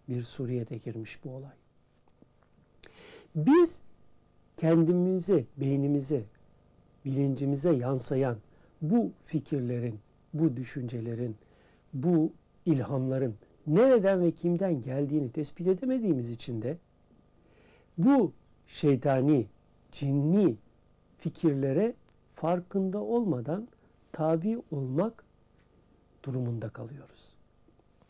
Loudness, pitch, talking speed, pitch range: -29 LUFS, 145 Hz, 75 wpm, 125-170 Hz